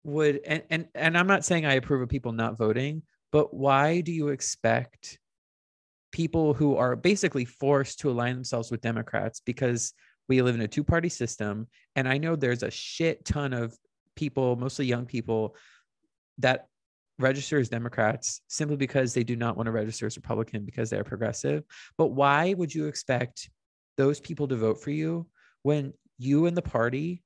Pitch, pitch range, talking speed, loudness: 135 Hz, 115-150 Hz, 180 wpm, -28 LUFS